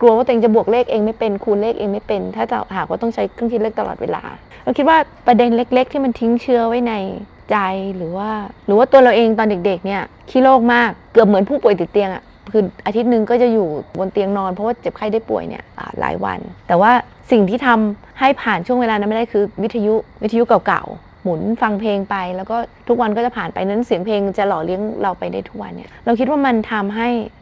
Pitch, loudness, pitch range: 220 Hz, -17 LUFS, 200-235 Hz